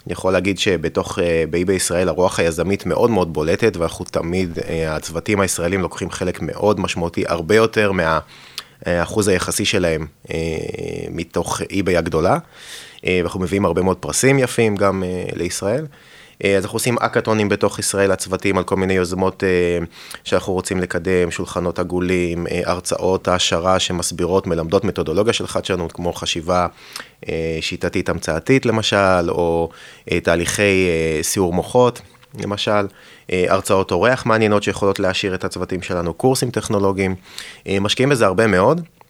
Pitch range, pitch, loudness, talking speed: 85-100 Hz, 95 Hz, -19 LUFS, 125 wpm